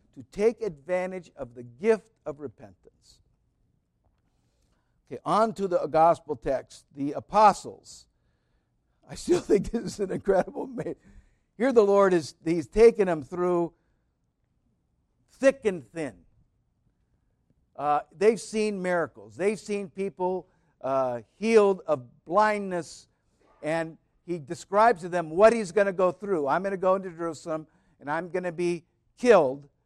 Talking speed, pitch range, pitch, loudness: 135 wpm, 150-205 Hz, 180 Hz, -26 LUFS